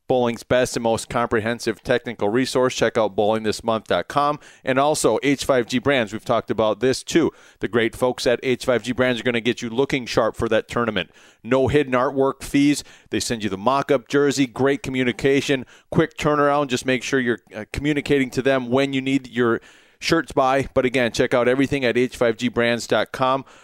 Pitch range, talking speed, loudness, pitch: 120-135 Hz, 180 wpm, -21 LUFS, 130 Hz